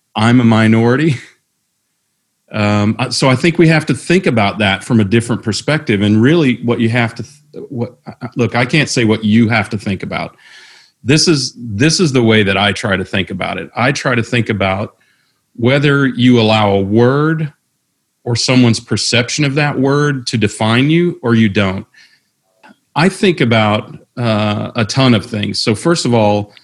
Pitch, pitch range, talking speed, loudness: 120 Hz, 110-140 Hz, 195 wpm, -13 LUFS